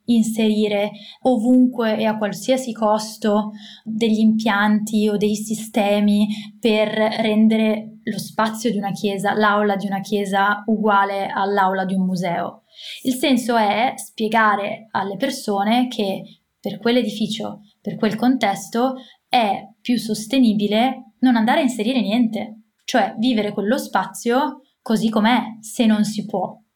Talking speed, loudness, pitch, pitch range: 130 wpm, -20 LUFS, 215 Hz, 205-235 Hz